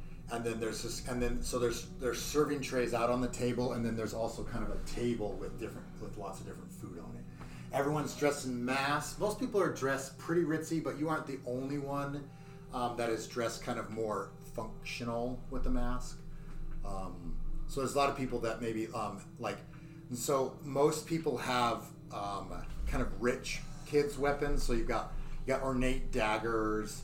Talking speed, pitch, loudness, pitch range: 195 wpm, 130 Hz, -36 LUFS, 115-150 Hz